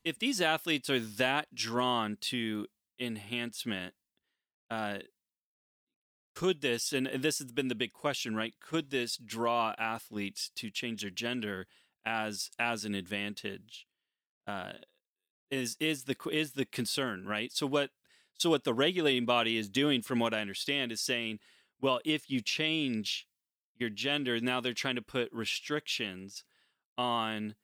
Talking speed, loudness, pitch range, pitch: 145 wpm, -33 LUFS, 110-135 Hz, 120 Hz